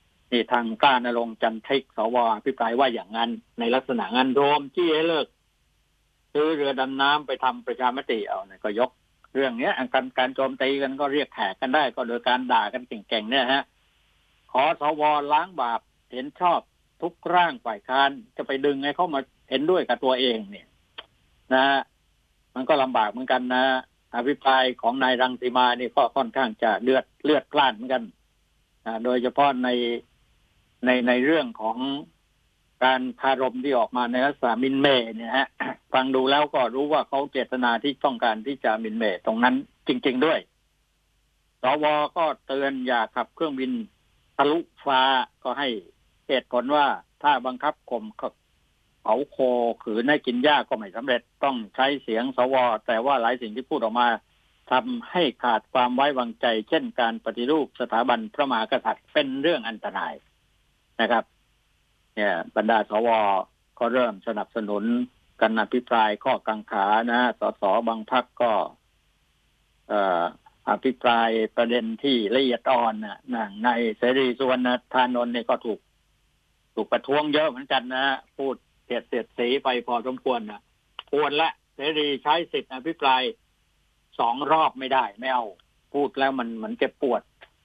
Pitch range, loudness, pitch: 120-140 Hz, -24 LUFS, 130 Hz